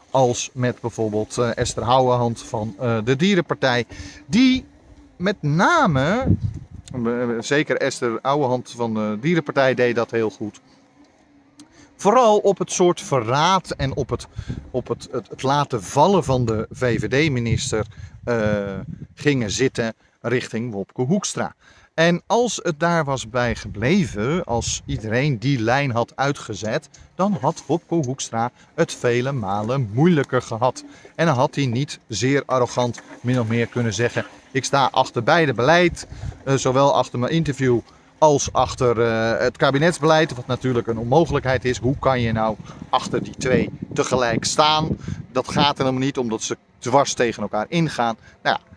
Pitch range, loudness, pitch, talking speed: 115-150 Hz, -21 LUFS, 130 Hz, 145 wpm